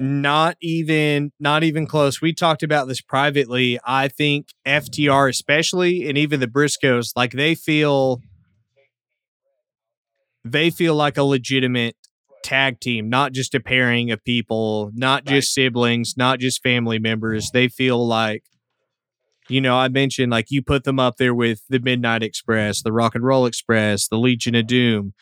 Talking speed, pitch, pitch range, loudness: 160 wpm, 130 Hz, 120-145 Hz, -19 LUFS